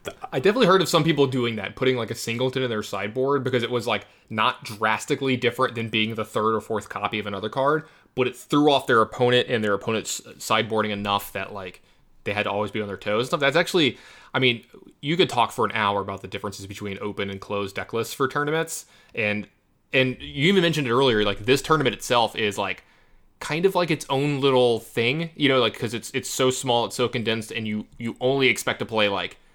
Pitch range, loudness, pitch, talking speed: 105-135 Hz, -23 LUFS, 120 Hz, 235 wpm